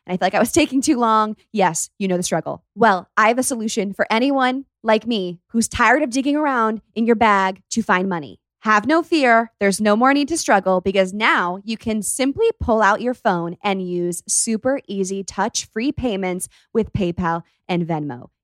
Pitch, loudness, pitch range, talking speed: 215 Hz, -19 LUFS, 185-235 Hz, 205 wpm